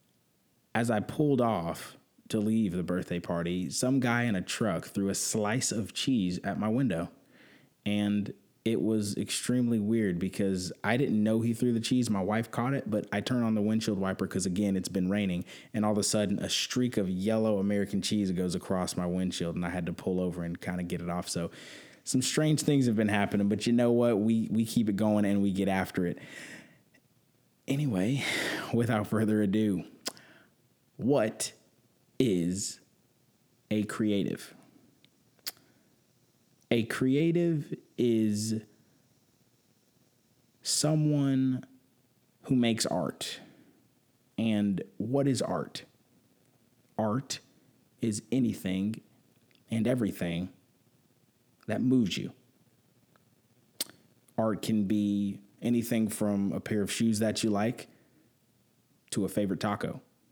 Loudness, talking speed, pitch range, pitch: -30 LUFS, 140 wpm, 100-120 Hz, 110 Hz